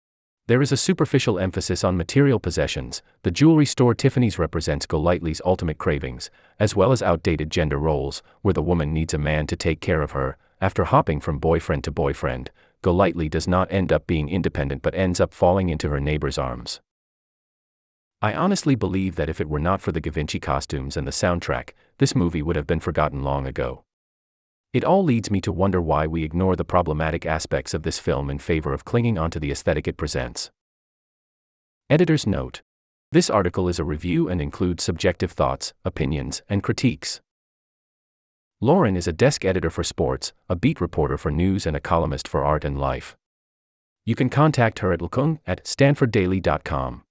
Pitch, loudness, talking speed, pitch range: 85 Hz, -22 LUFS, 180 wpm, 75-100 Hz